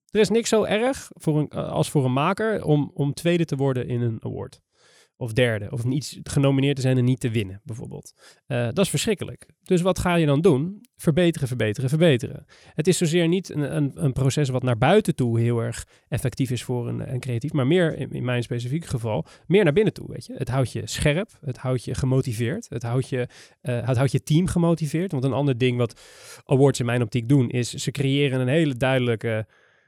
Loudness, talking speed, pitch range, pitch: -23 LUFS, 220 wpm, 125-160 Hz, 135 Hz